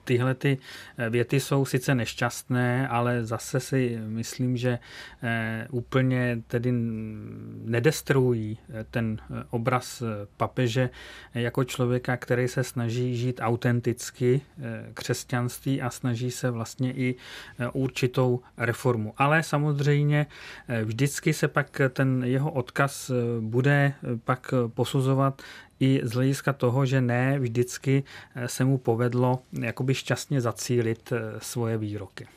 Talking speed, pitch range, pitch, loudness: 105 wpm, 120-135 Hz, 125 Hz, -27 LUFS